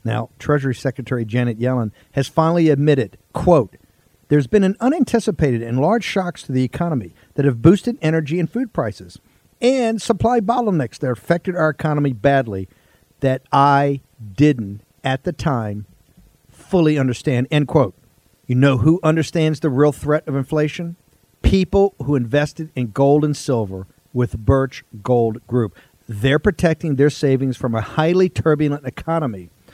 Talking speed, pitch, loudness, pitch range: 145 wpm, 140 Hz, -18 LUFS, 125-160 Hz